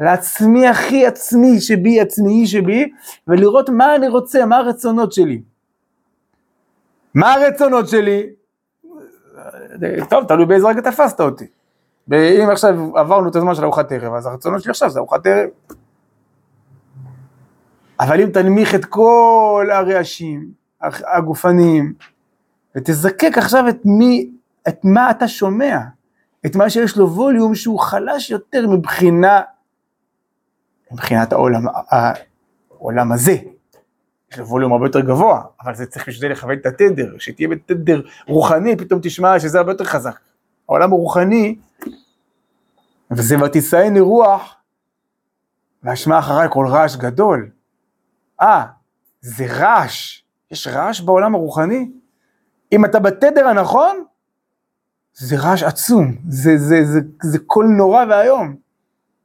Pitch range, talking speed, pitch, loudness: 150-230 Hz, 115 wpm, 190 Hz, -14 LUFS